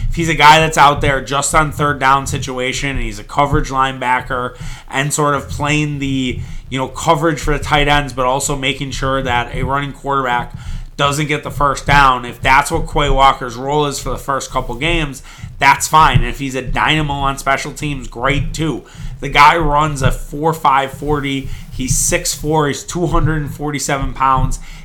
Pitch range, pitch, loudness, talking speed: 130-150 Hz, 140 Hz, -15 LUFS, 195 wpm